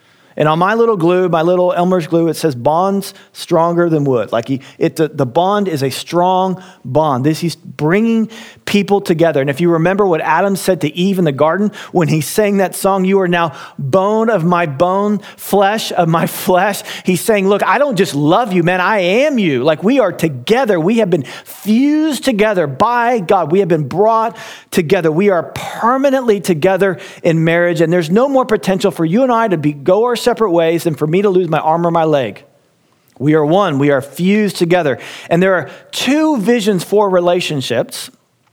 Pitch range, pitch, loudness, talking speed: 165-205 Hz, 185 Hz, -14 LUFS, 205 wpm